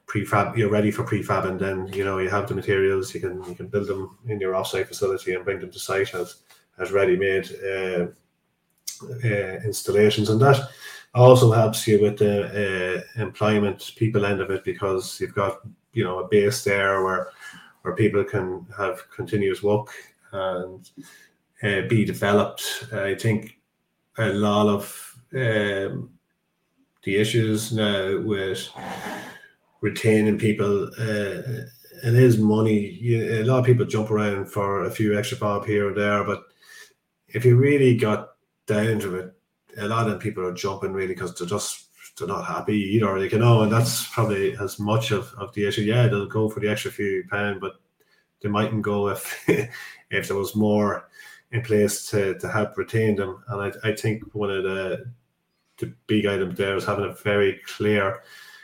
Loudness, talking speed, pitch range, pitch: -23 LUFS, 175 wpm, 100-110 Hz, 105 Hz